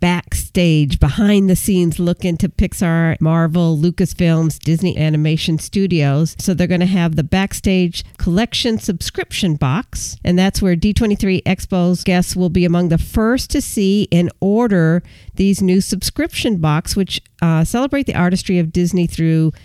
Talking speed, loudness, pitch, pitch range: 150 wpm, -16 LUFS, 180 Hz, 165-195 Hz